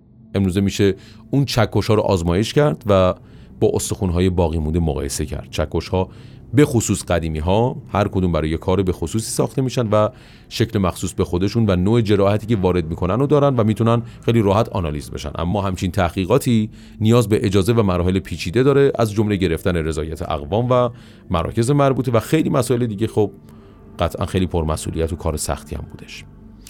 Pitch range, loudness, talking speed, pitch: 90-115 Hz, -19 LUFS, 180 wpm, 100 Hz